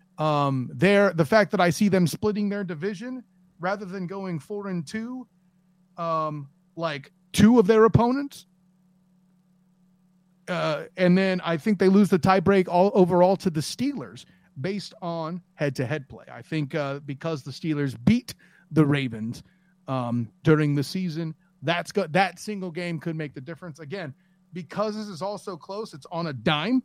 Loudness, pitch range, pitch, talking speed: -24 LUFS, 160-195 Hz, 180 Hz, 170 wpm